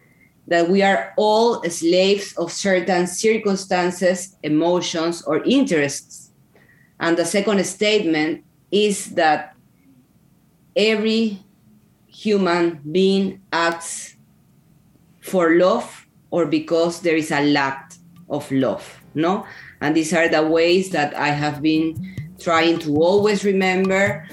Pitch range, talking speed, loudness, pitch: 160-195 Hz, 110 wpm, -19 LUFS, 170 Hz